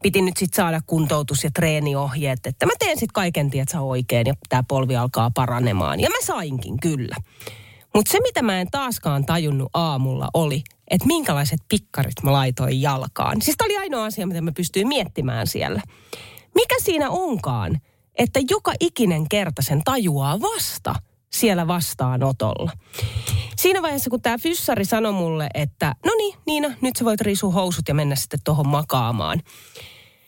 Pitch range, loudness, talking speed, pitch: 130-215 Hz, -21 LUFS, 160 wpm, 160 Hz